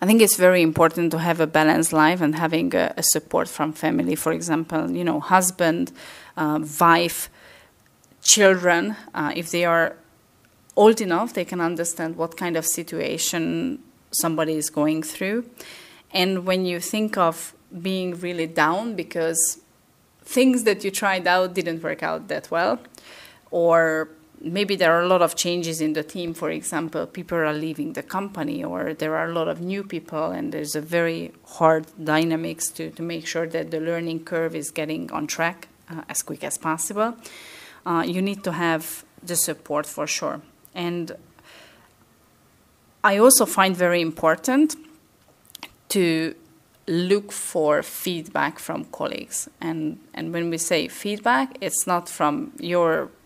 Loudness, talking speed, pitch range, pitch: -22 LUFS, 160 wpm, 160-180 Hz, 170 Hz